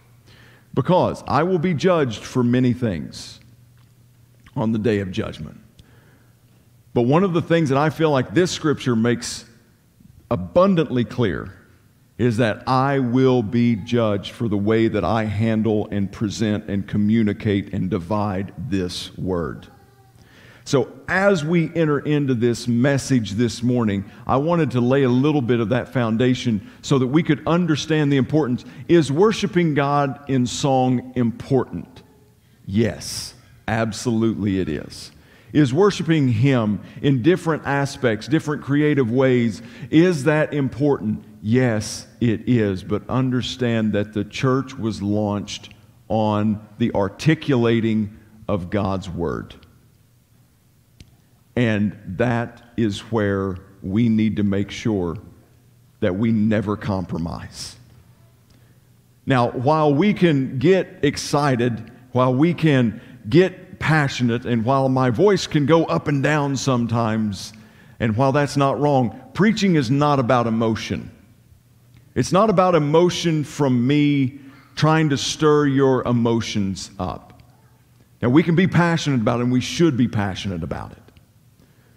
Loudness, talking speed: -20 LUFS, 130 wpm